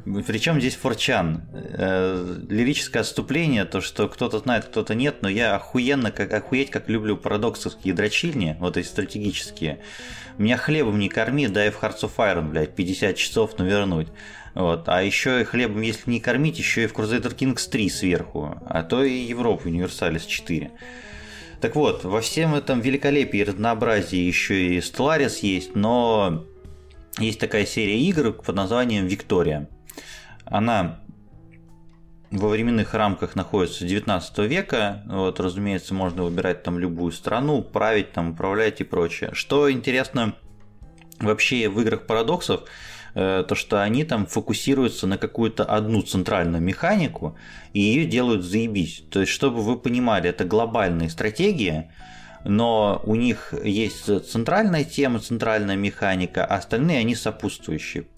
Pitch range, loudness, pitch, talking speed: 95-120 Hz, -23 LUFS, 105 Hz, 140 wpm